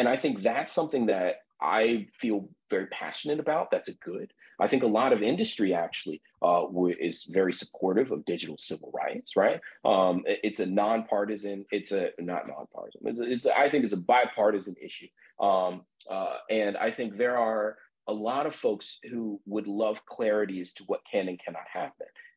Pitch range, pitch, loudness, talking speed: 100-115 Hz, 105 Hz, -29 LUFS, 185 wpm